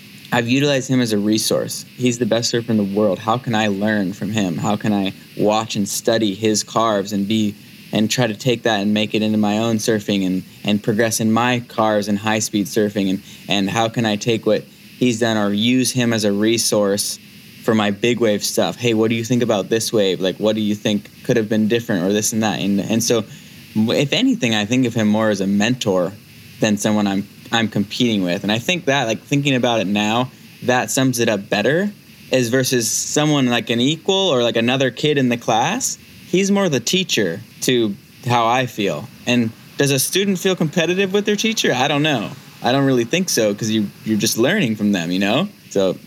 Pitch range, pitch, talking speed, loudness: 105-125 Hz, 115 Hz, 225 wpm, -18 LUFS